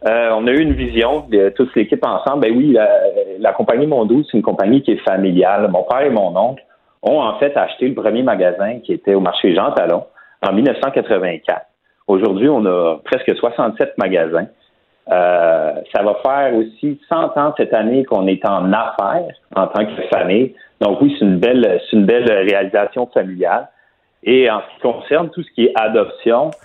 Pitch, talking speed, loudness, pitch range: 125 Hz, 190 wpm, -15 LUFS, 105-165 Hz